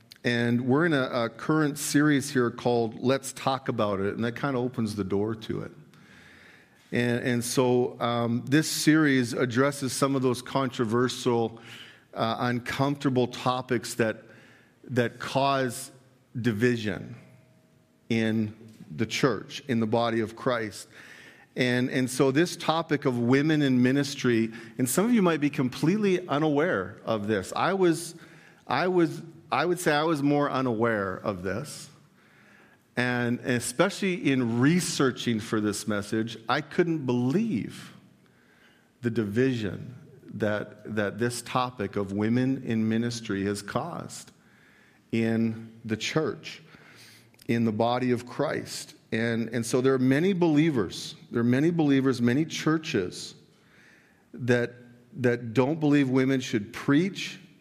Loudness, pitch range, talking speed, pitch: -27 LUFS, 115-145 Hz, 135 wpm, 125 Hz